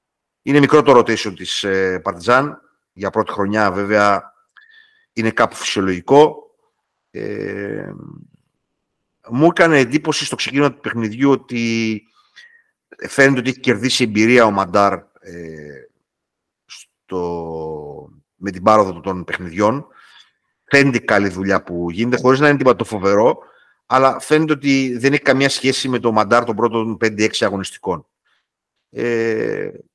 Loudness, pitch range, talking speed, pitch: -16 LUFS, 100-140 Hz, 130 wpm, 120 Hz